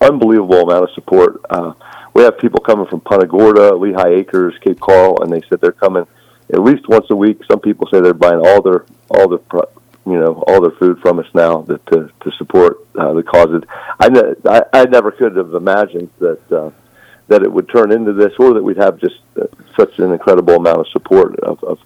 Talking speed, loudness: 215 wpm, -11 LUFS